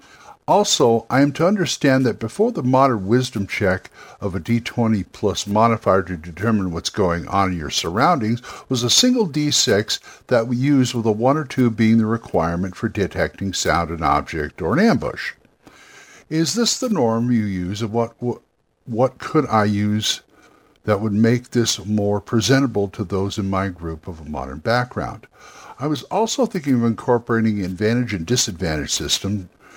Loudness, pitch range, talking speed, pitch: -20 LUFS, 100-130 Hz, 170 wpm, 115 Hz